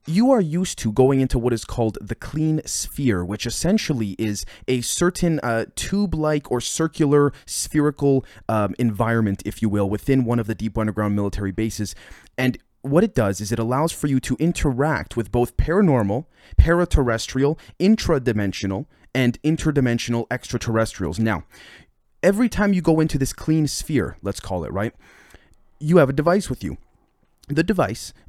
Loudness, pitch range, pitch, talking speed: -21 LUFS, 110-155 Hz, 125 Hz, 160 wpm